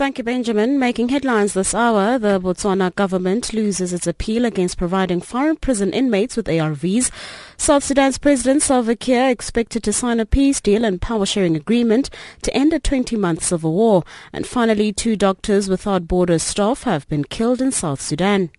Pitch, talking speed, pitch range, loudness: 215 Hz, 170 wpm, 185-250 Hz, -18 LUFS